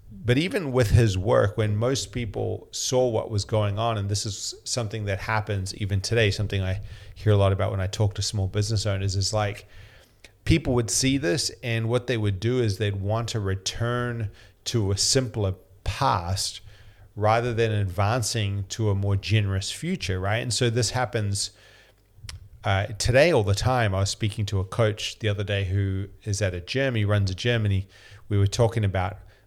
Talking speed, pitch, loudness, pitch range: 190 wpm, 105 Hz, -25 LUFS, 100-115 Hz